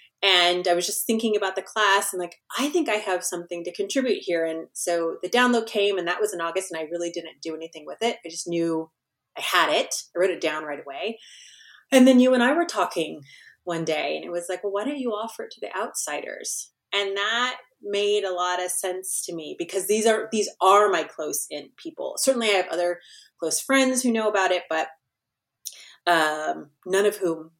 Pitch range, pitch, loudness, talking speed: 170-215 Hz, 185 Hz, -24 LUFS, 225 wpm